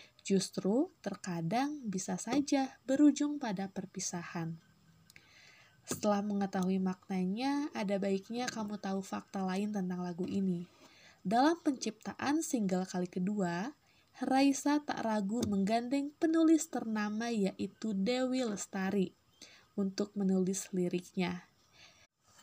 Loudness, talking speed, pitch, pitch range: -34 LUFS, 95 wpm, 200 Hz, 185-255 Hz